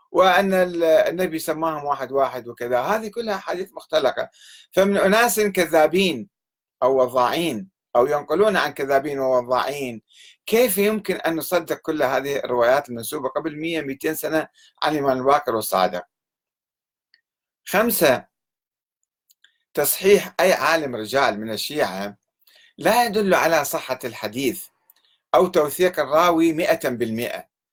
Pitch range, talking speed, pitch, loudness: 135-190 Hz, 115 wpm, 160 Hz, -21 LUFS